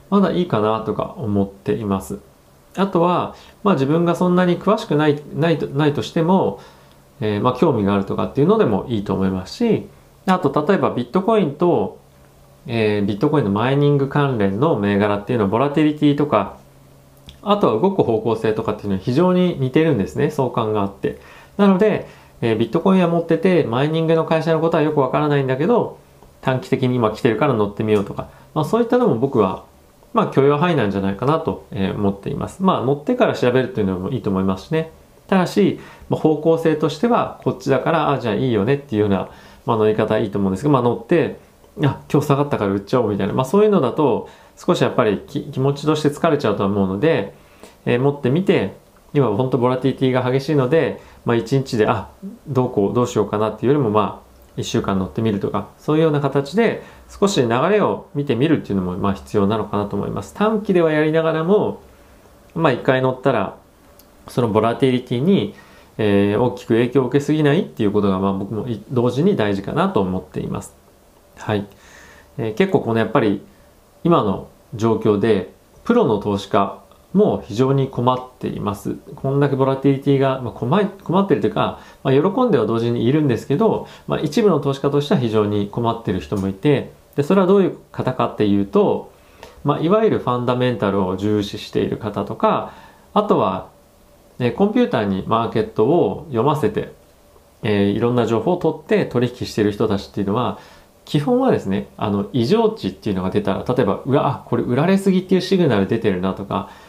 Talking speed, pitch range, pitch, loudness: 425 characters per minute, 105-155 Hz, 125 Hz, -19 LUFS